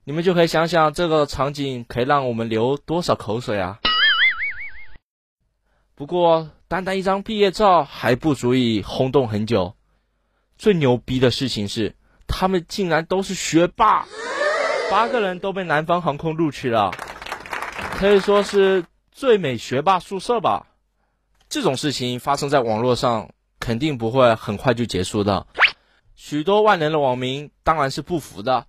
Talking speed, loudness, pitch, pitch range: 230 characters per minute, -20 LUFS, 145 Hz, 125-185 Hz